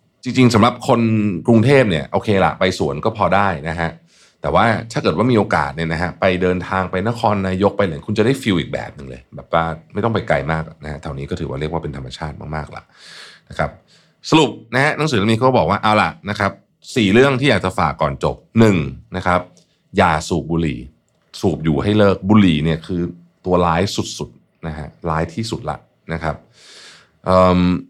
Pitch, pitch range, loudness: 90 Hz, 80-105 Hz, -17 LUFS